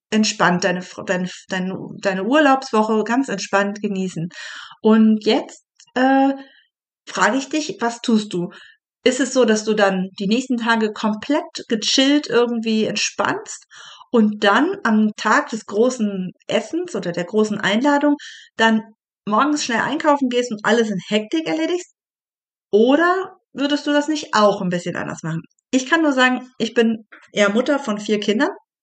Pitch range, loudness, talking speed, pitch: 210-275 Hz, -19 LUFS, 150 wpm, 225 Hz